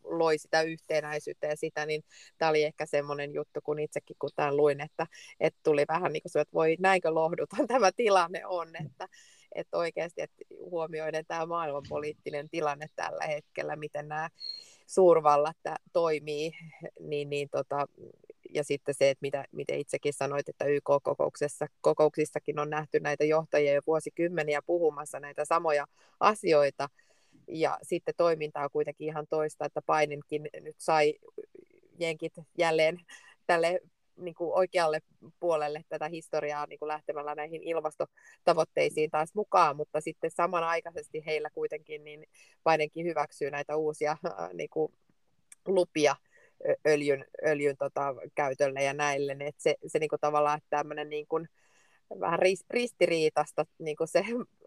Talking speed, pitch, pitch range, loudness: 135 wpm, 155 Hz, 150-170 Hz, -30 LUFS